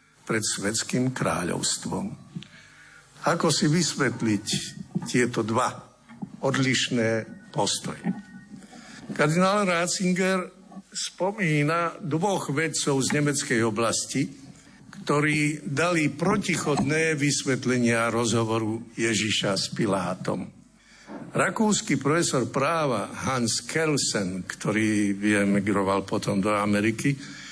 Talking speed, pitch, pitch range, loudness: 80 wpm, 140 Hz, 115-170 Hz, -25 LUFS